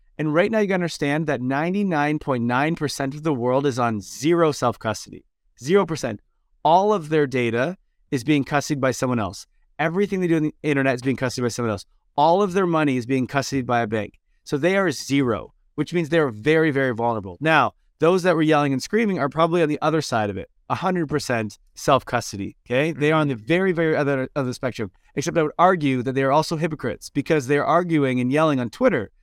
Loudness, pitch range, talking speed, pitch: -22 LUFS, 130-165 Hz, 205 wpm, 145 Hz